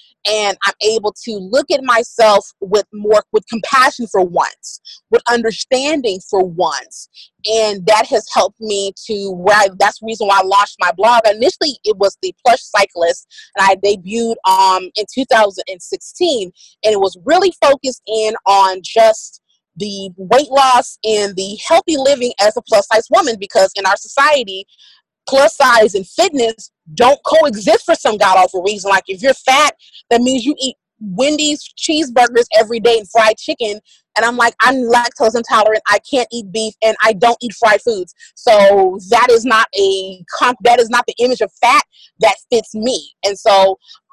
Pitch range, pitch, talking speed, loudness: 200-255 Hz, 220 Hz, 175 wpm, -13 LUFS